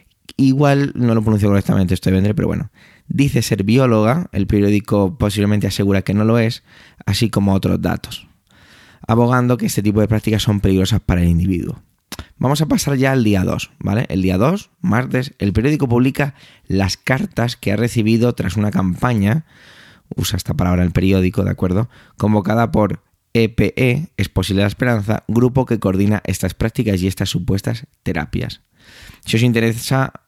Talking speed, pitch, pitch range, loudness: 165 wpm, 110 Hz, 100-125 Hz, -17 LUFS